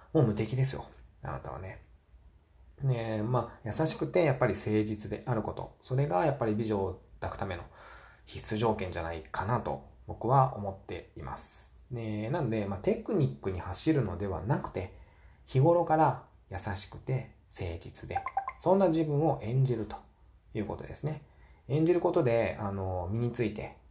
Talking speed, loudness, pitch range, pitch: 320 characters per minute, -32 LUFS, 95-140 Hz, 110 Hz